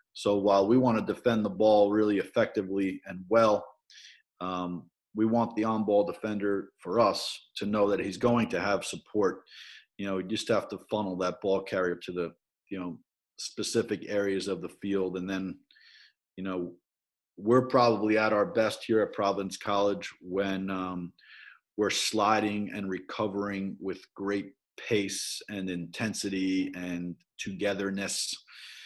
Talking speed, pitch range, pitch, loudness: 150 wpm, 95-105 Hz, 100 Hz, -29 LUFS